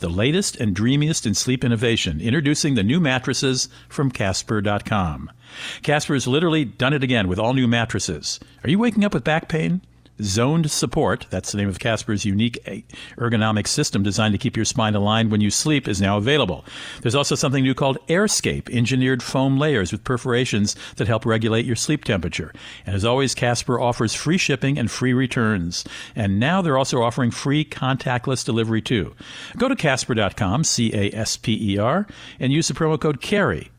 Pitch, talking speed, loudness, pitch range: 125 Hz, 175 wpm, -21 LUFS, 110-145 Hz